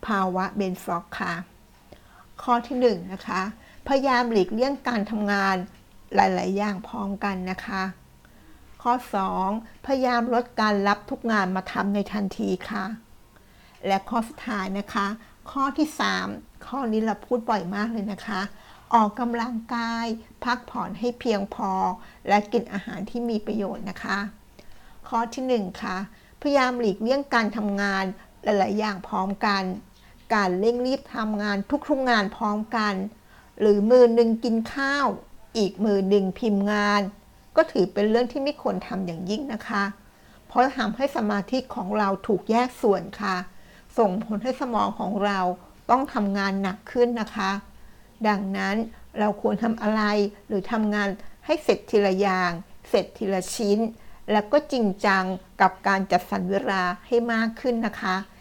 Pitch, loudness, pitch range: 210 Hz, -25 LUFS, 195-235 Hz